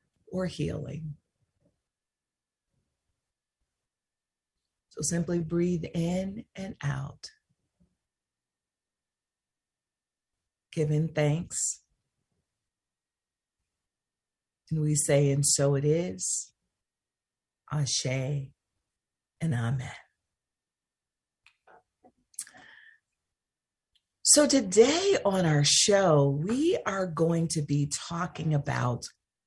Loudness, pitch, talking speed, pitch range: -27 LUFS, 150 Hz, 65 wpm, 140-180 Hz